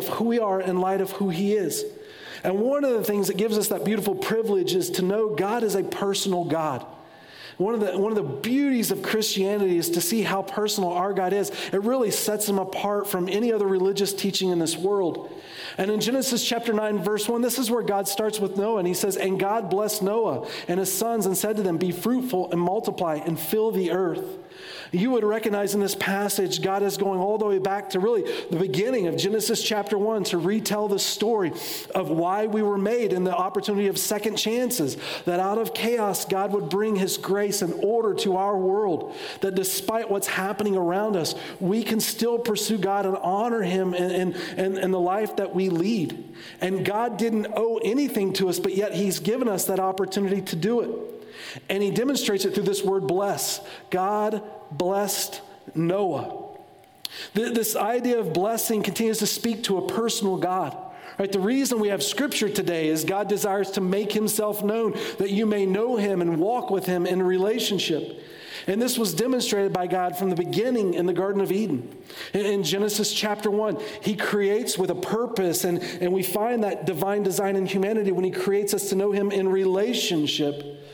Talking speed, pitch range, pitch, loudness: 200 wpm, 190-220 Hz, 200 Hz, -24 LUFS